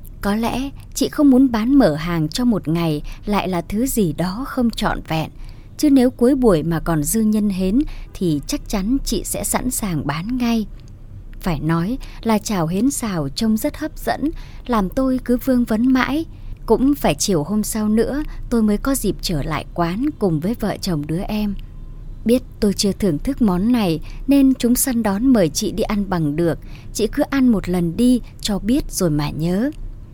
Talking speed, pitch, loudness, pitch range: 200 wpm, 210 Hz, -19 LUFS, 165-250 Hz